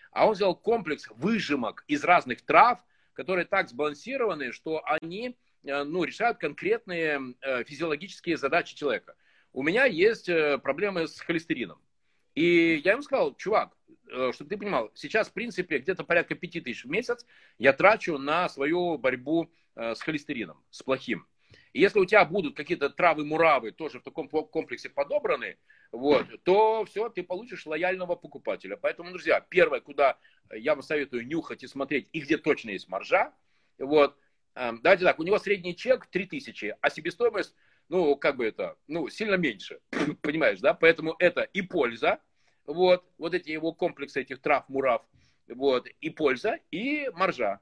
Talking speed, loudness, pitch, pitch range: 150 wpm, -27 LUFS, 175 Hz, 155-220 Hz